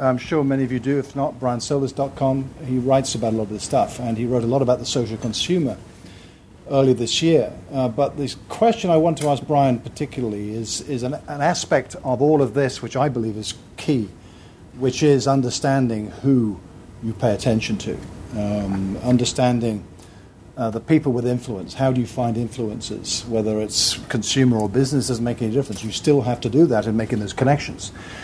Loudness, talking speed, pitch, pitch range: -21 LUFS, 195 wpm, 125 Hz, 110-135 Hz